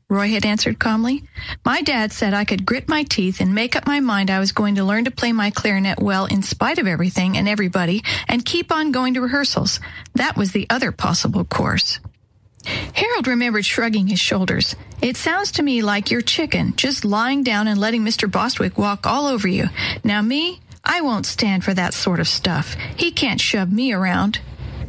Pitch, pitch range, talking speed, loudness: 220 Hz, 200-255 Hz, 200 wpm, -19 LUFS